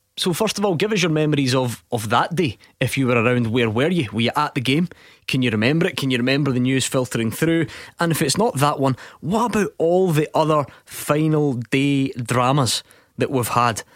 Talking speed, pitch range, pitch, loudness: 225 wpm, 125-160 Hz, 135 Hz, -20 LUFS